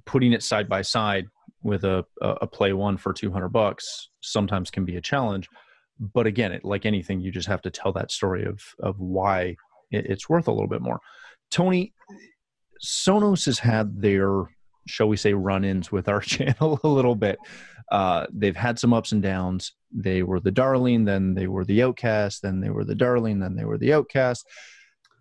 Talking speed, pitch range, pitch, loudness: 195 wpm, 95-120 Hz, 100 Hz, -24 LUFS